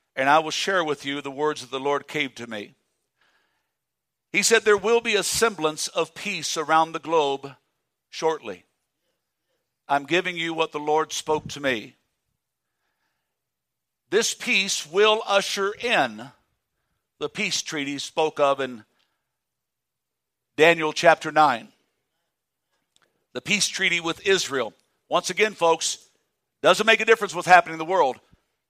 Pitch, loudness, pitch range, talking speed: 160 Hz, -22 LUFS, 145-195 Hz, 140 wpm